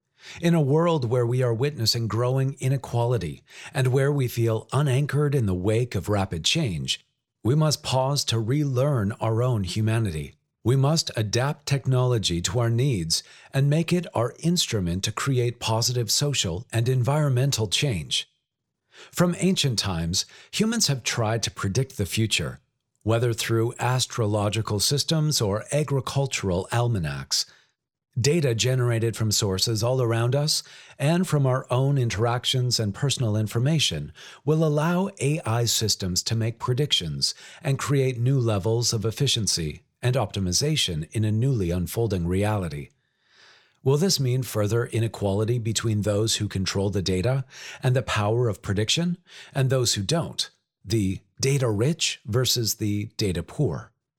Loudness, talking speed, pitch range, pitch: -24 LUFS, 140 wpm, 105-135 Hz, 120 Hz